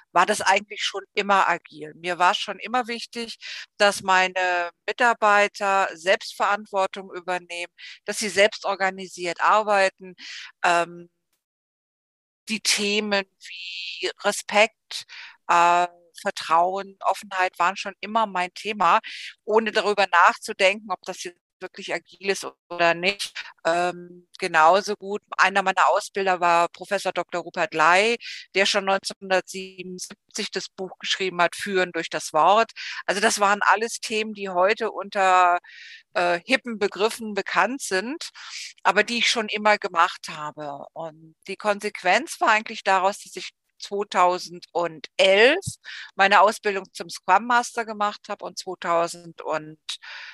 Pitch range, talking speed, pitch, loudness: 175-210 Hz, 125 wpm, 190 Hz, -22 LUFS